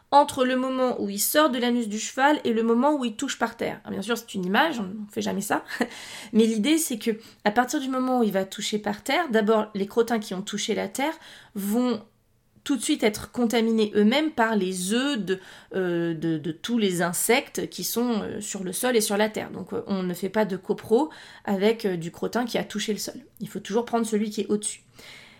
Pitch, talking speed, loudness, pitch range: 220 Hz, 235 wpm, -25 LUFS, 200-245 Hz